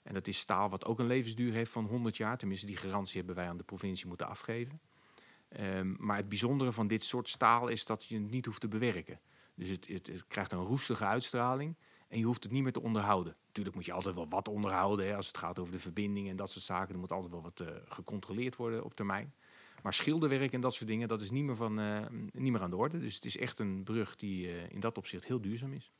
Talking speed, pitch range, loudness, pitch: 260 wpm, 95-120 Hz, -37 LUFS, 105 Hz